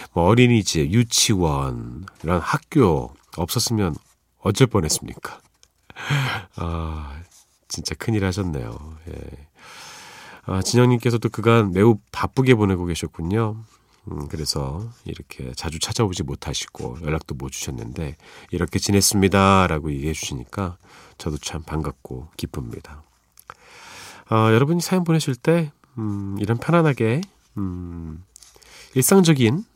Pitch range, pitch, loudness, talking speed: 80-115 Hz, 95 Hz, -21 LUFS, 260 characters per minute